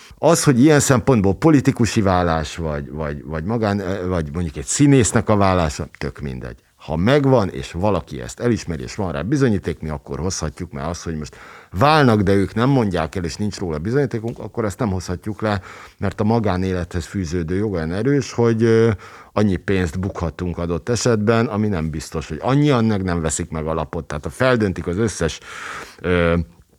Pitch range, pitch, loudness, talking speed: 85-115 Hz, 95 Hz, -19 LUFS, 175 wpm